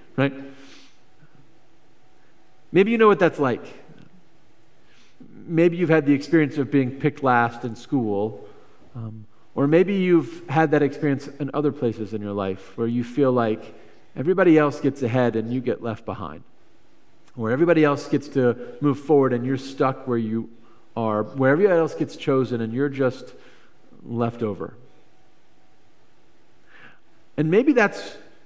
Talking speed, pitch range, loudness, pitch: 150 wpm, 115-150 Hz, -22 LUFS, 135 Hz